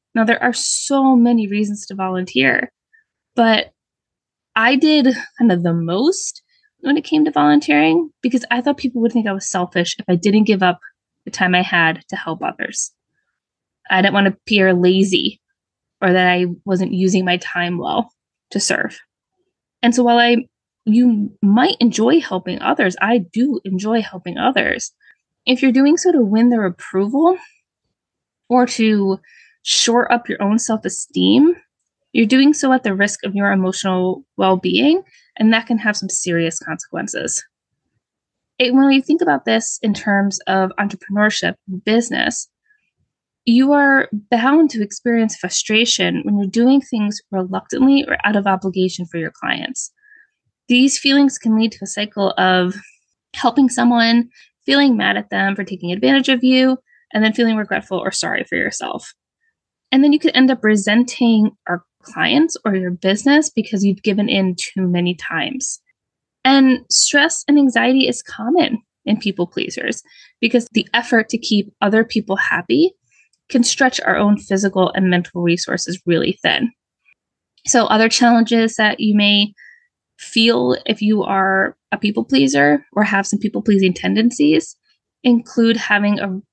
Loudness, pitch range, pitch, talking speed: -16 LUFS, 195-260 Hz, 220 Hz, 155 wpm